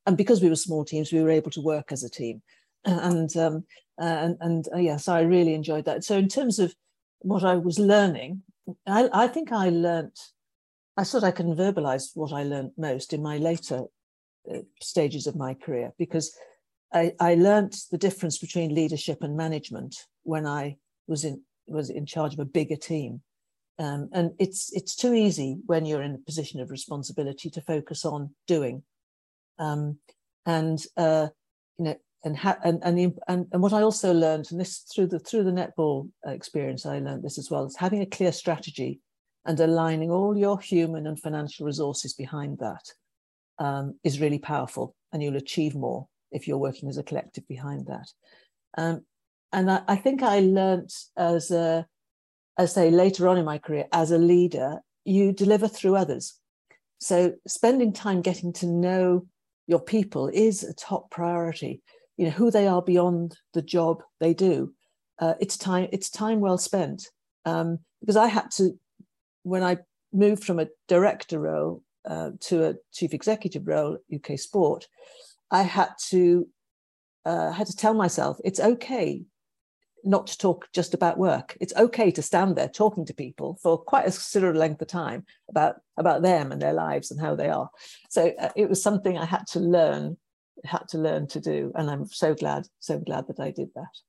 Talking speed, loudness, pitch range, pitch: 185 wpm, -26 LUFS, 155-190 Hz, 170 Hz